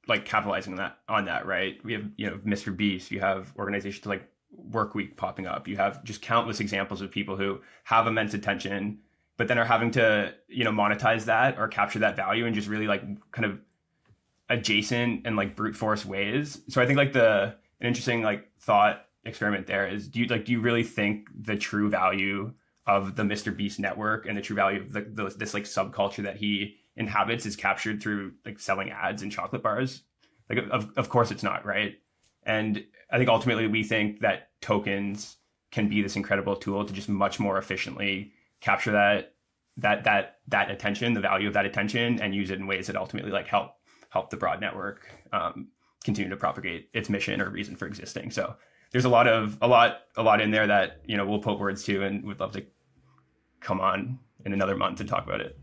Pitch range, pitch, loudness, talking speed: 100-110 Hz, 105 Hz, -27 LUFS, 210 wpm